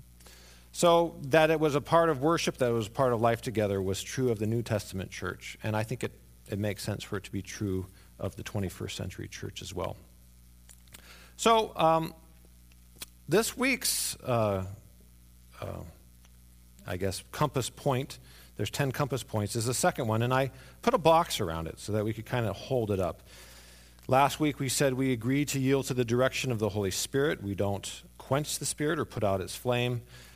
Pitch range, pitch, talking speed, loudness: 85-130 Hz, 105 Hz, 200 wpm, -30 LUFS